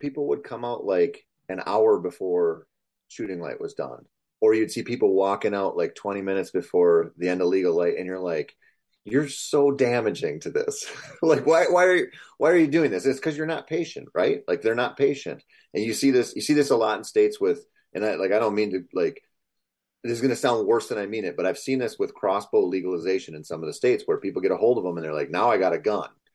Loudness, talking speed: -24 LUFS, 255 wpm